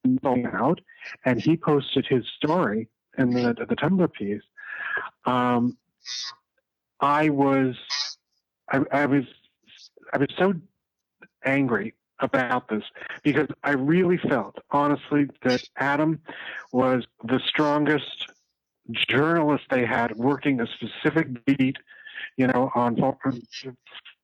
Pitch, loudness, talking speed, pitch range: 140 Hz, -24 LUFS, 110 wpm, 125-155 Hz